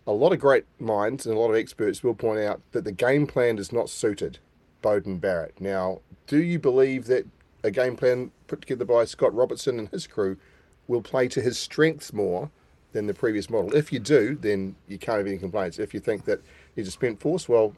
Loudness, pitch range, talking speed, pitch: -25 LUFS, 100-130 Hz, 225 wpm, 115 Hz